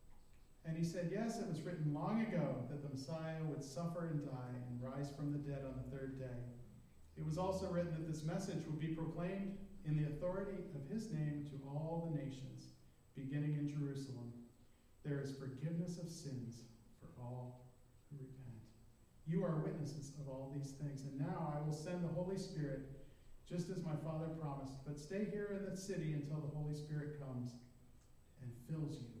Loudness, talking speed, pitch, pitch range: -45 LUFS, 185 wpm, 145 Hz, 130-165 Hz